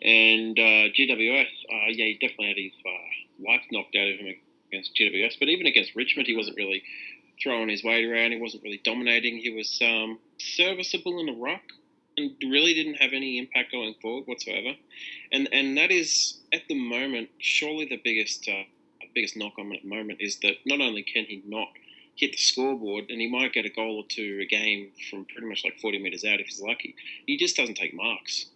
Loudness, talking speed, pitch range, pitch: -25 LUFS, 210 wpm, 105-135 Hz, 115 Hz